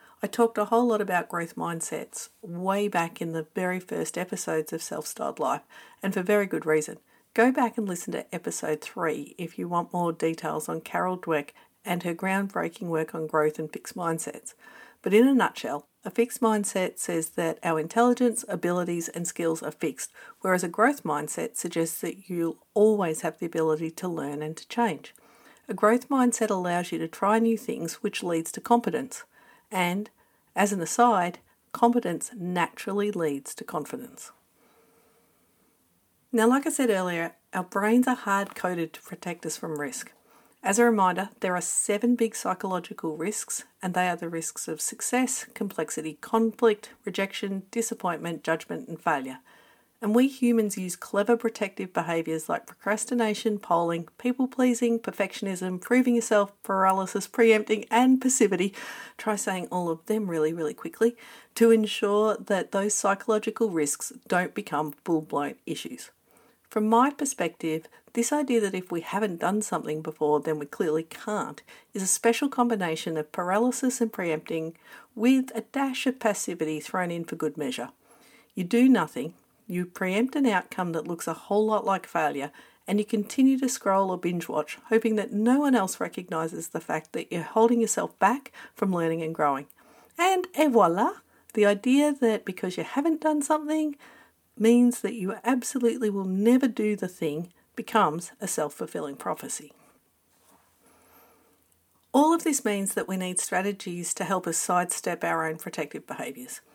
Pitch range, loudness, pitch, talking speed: 170-230 Hz, -27 LUFS, 200 Hz, 165 wpm